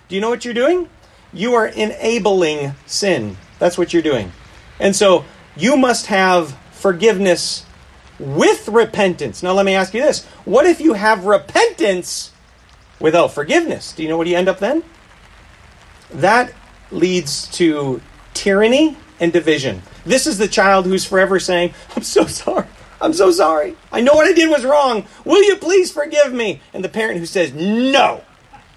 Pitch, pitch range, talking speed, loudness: 195 Hz, 170-245 Hz, 165 wpm, -15 LUFS